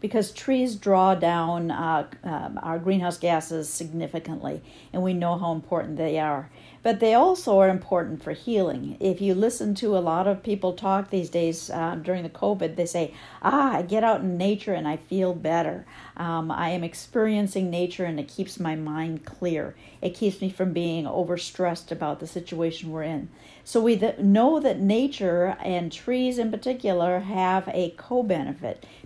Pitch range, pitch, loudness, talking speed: 165-200 Hz, 180 Hz, -25 LUFS, 180 wpm